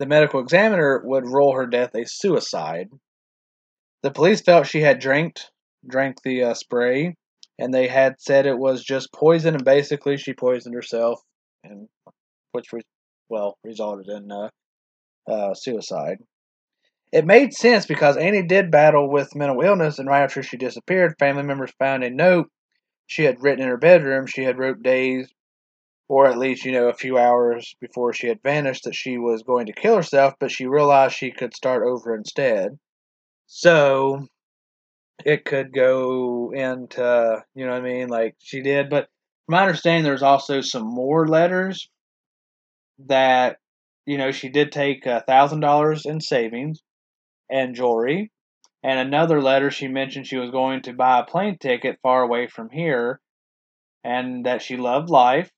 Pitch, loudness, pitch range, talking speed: 135 Hz, -20 LUFS, 125-145 Hz, 165 wpm